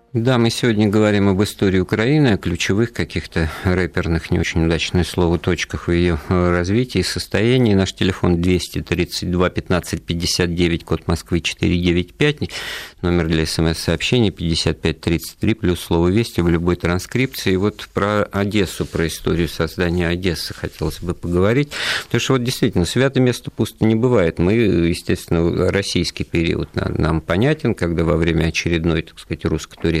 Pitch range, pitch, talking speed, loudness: 85-105 Hz, 90 Hz, 145 wpm, -19 LUFS